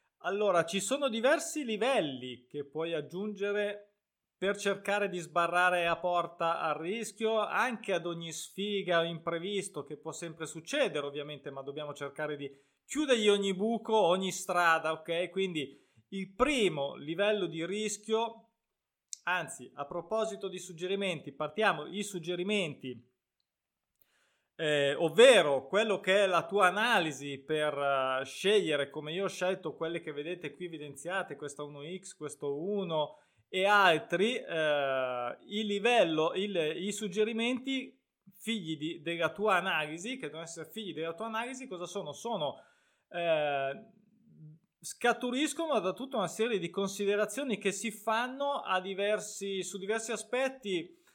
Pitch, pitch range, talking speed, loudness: 185 Hz, 155-210 Hz, 135 wpm, -32 LUFS